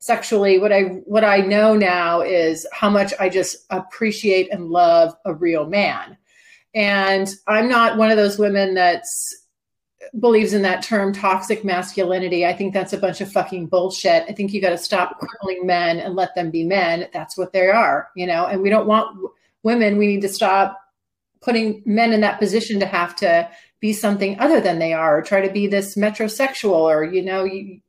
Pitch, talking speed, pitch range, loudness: 195 Hz, 200 wpm, 185-215 Hz, -18 LUFS